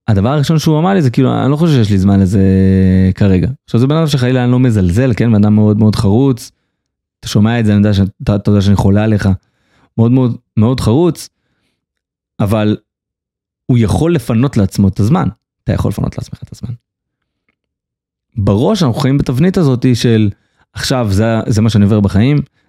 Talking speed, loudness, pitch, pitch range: 185 wpm, -12 LUFS, 115 Hz, 100-130 Hz